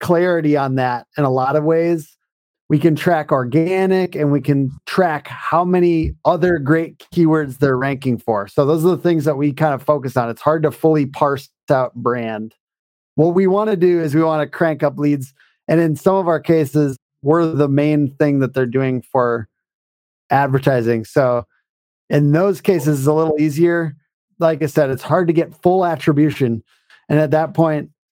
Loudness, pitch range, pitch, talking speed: -17 LUFS, 135-165 Hz, 150 Hz, 190 wpm